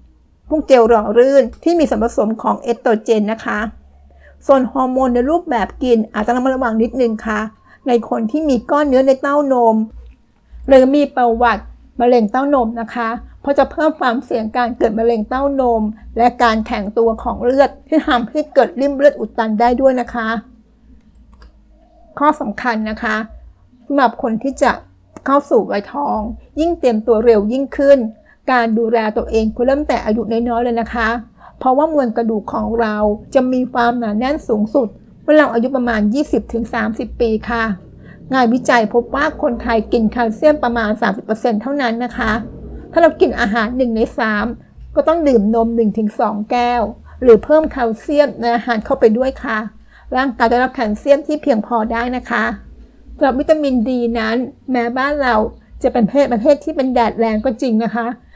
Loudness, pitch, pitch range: -16 LUFS, 240 Hz, 230-270 Hz